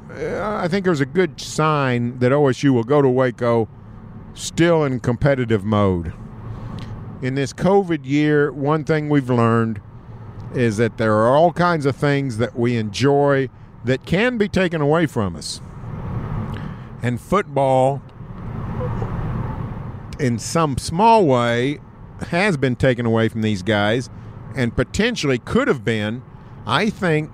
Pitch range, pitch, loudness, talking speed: 115-145 Hz, 125 Hz, -19 LUFS, 135 wpm